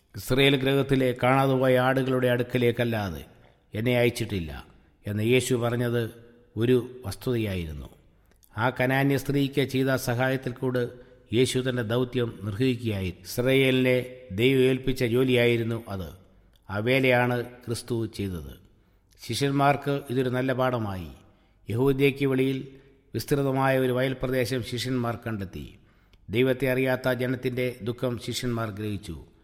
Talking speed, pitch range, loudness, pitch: 100 wpm, 105-130 Hz, -26 LUFS, 125 Hz